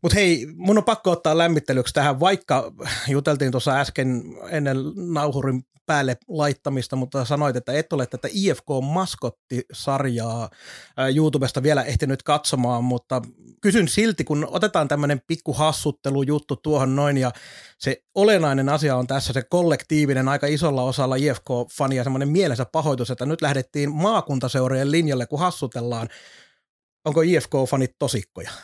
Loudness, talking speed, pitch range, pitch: -22 LUFS, 135 wpm, 130-155 Hz, 140 Hz